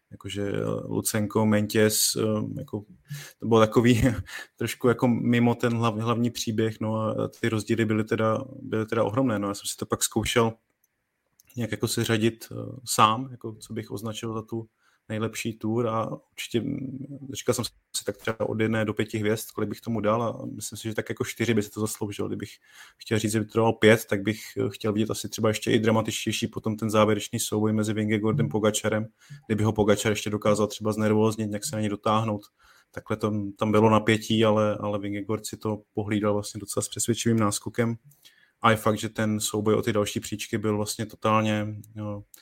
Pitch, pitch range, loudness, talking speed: 110 Hz, 105-115 Hz, -26 LUFS, 190 wpm